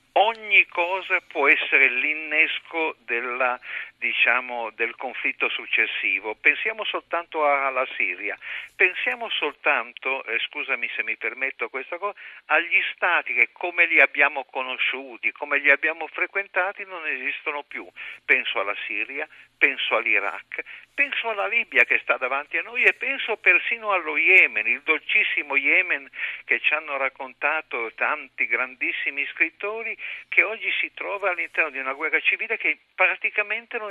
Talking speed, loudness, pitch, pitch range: 135 wpm, -22 LUFS, 160 Hz, 135-195 Hz